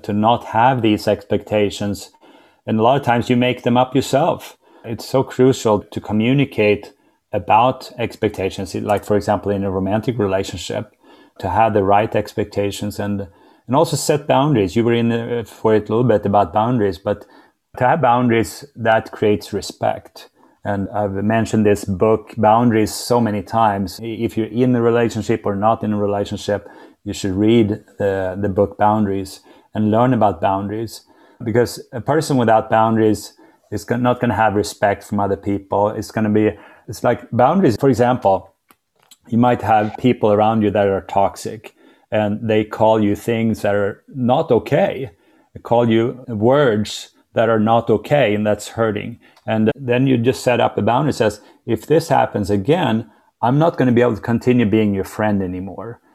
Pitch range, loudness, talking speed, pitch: 105-120 Hz, -18 LUFS, 175 wpm, 110 Hz